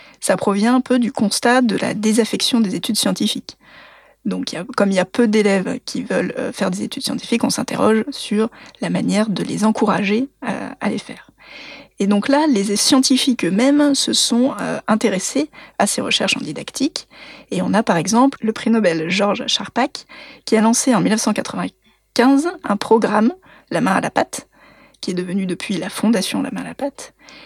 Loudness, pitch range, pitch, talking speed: -18 LUFS, 205-260 Hz, 230 Hz, 190 wpm